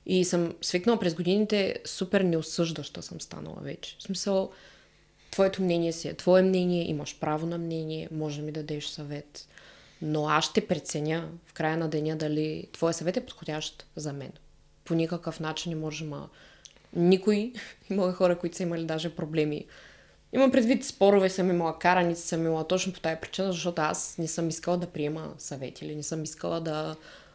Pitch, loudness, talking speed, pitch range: 165 Hz, -29 LUFS, 180 wpm, 155-185 Hz